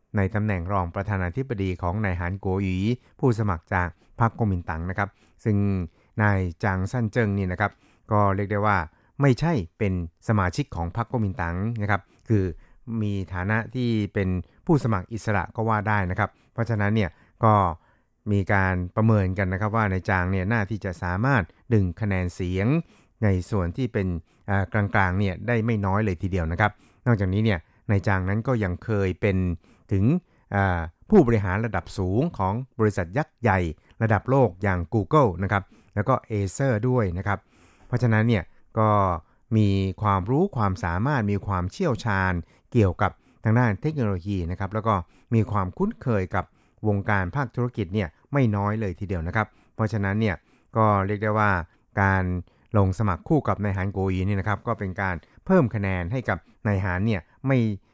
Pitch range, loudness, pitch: 95-110 Hz, -25 LUFS, 105 Hz